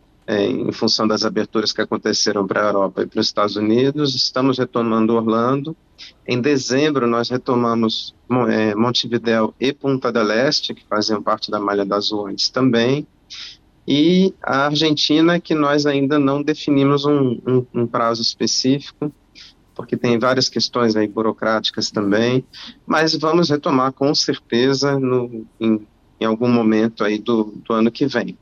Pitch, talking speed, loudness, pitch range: 120 Hz, 150 wpm, -18 LUFS, 110-140 Hz